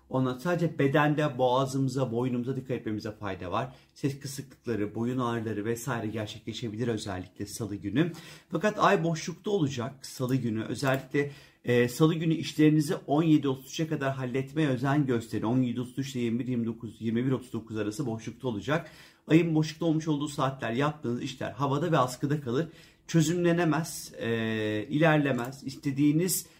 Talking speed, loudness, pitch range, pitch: 125 wpm, -29 LUFS, 115-155 Hz, 135 Hz